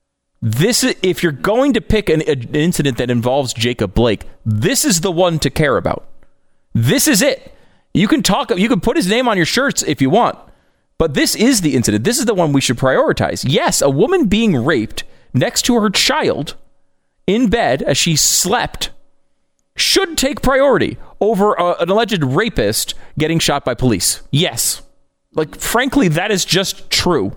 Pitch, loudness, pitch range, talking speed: 170 Hz, -15 LUFS, 135-220 Hz, 180 wpm